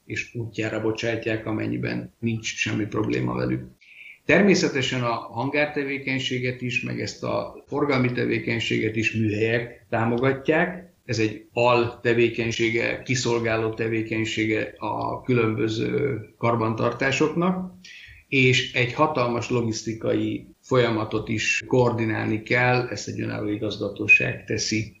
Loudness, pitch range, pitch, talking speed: -24 LUFS, 110-125 Hz, 115 Hz, 100 wpm